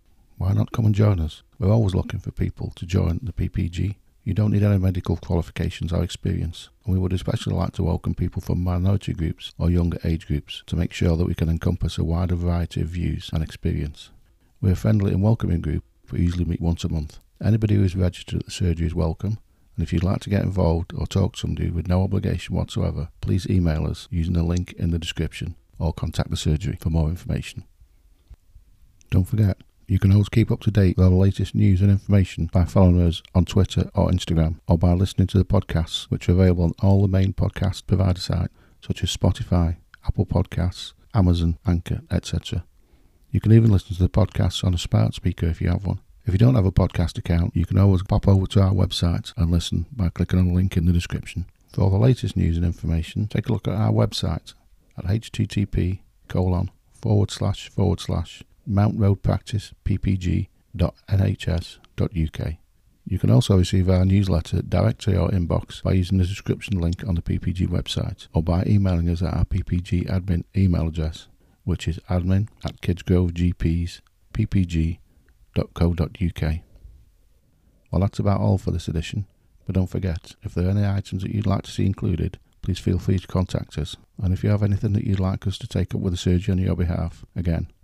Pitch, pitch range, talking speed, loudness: 95 Hz, 85-100 Hz, 200 wpm, -23 LUFS